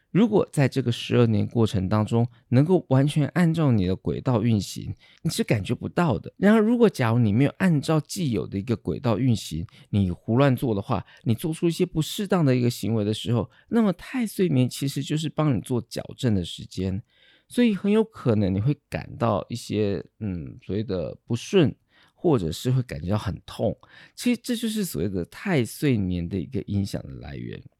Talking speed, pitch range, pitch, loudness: 295 characters per minute, 105-155 Hz, 125 Hz, -24 LUFS